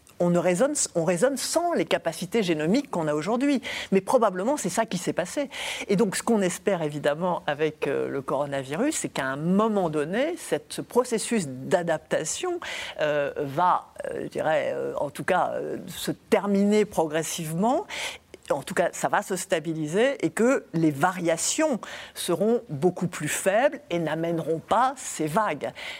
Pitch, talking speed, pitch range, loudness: 190 Hz, 160 wpm, 165-250 Hz, -26 LUFS